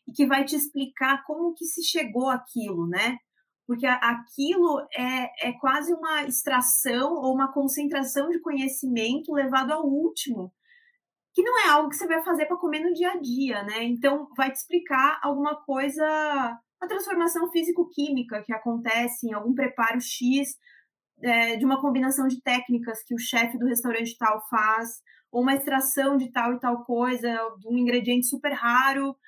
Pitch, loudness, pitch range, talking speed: 265 Hz, -25 LUFS, 245-300 Hz, 170 wpm